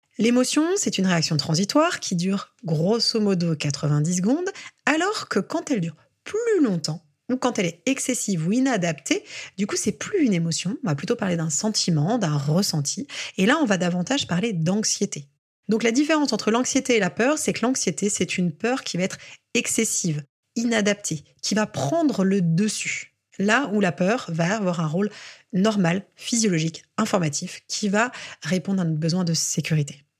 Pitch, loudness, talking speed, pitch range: 195 Hz, -23 LUFS, 175 wpm, 170-235 Hz